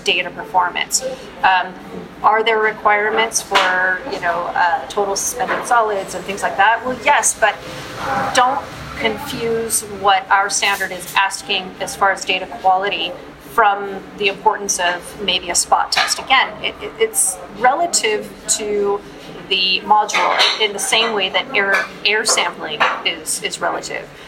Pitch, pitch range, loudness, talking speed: 205 Hz, 190-225 Hz, -17 LUFS, 145 wpm